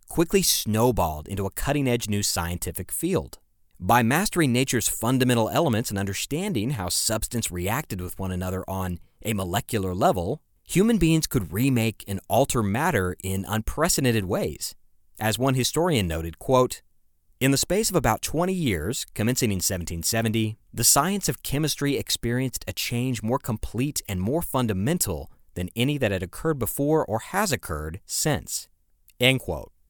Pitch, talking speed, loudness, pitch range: 110 Hz, 150 wpm, -24 LUFS, 95-130 Hz